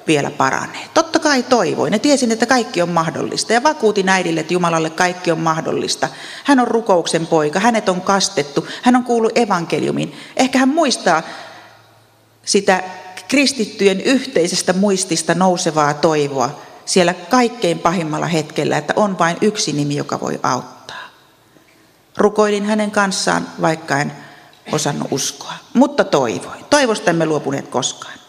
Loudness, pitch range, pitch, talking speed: -16 LUFS, 165-235 Hz, 190 Hz, 135 wpm